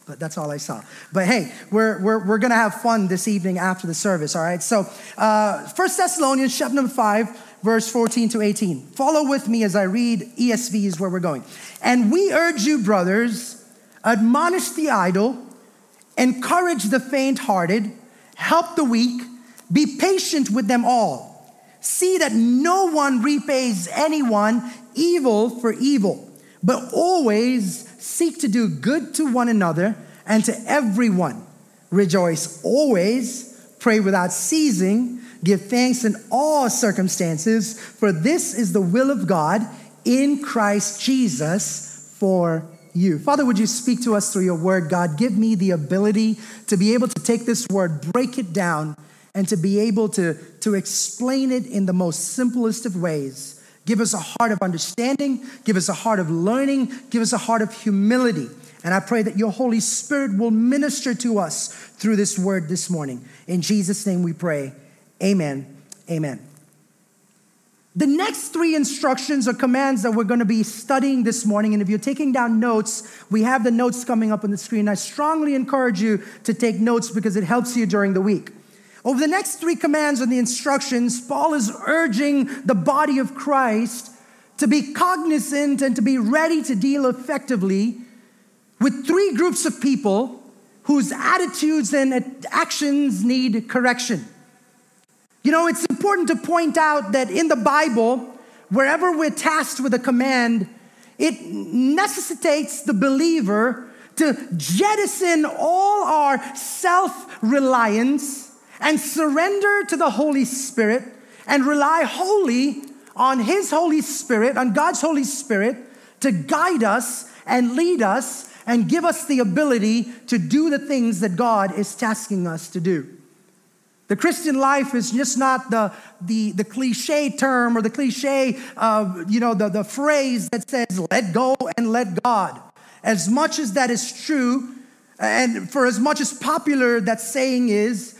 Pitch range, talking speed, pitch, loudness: 210-275 Hz, 160 wpm, 240 Hz, -20 LUFS